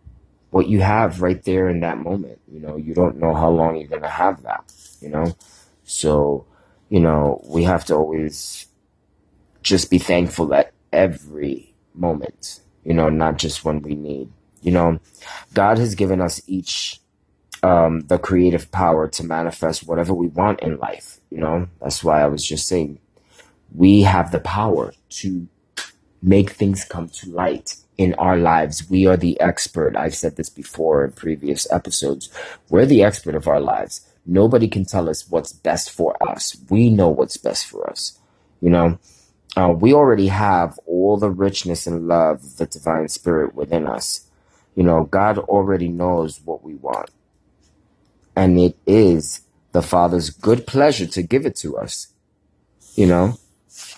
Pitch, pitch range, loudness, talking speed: 85 Hz, 80-95 Hz, -19 LUFS, 165 wpm